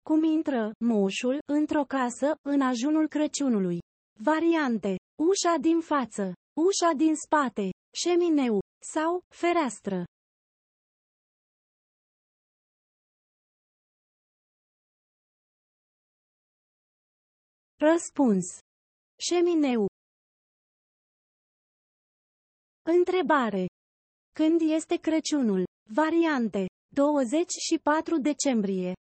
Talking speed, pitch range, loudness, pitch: 55 wpm, 230-325 Hz, -26 LUFS, 295 Hz